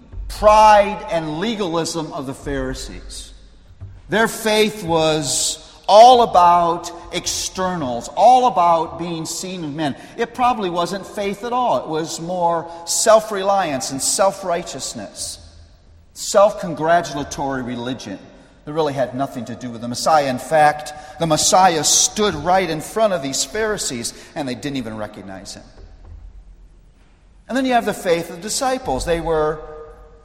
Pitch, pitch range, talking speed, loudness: 160 Hz, 130-195 Hz, 145 wpm, -18 LUFS